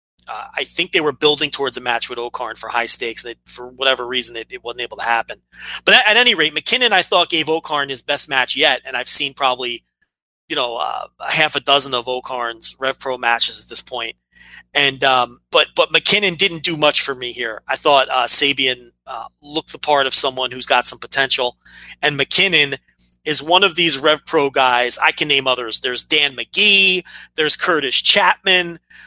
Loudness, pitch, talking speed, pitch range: -15 LUFS, 140 Hz, 200 wpm, 125-155 Hz